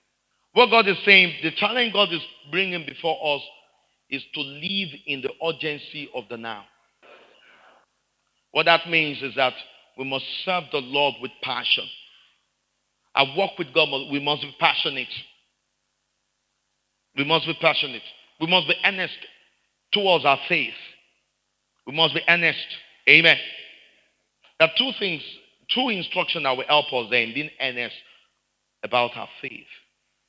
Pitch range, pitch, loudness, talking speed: 135-175 Hz, 155 Hz, -21 LUFS, 145 wpm